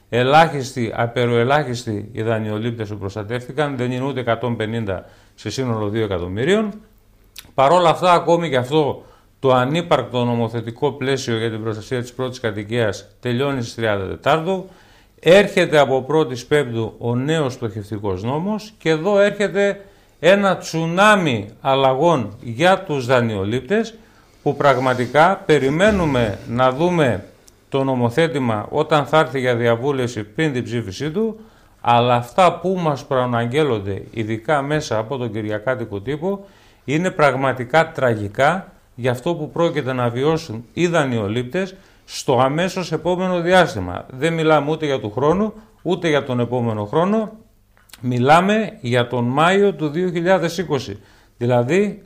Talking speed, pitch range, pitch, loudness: 130 wpm, 115-165 Hz, 130 Hz, -19 LUFS